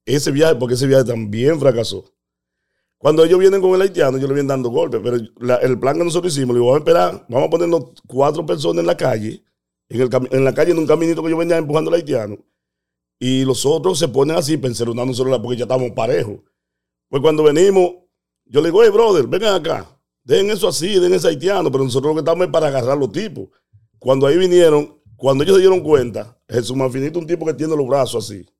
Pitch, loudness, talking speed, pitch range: 140 Hz, -16 LUFS, 225 wpm, 125-170 Hz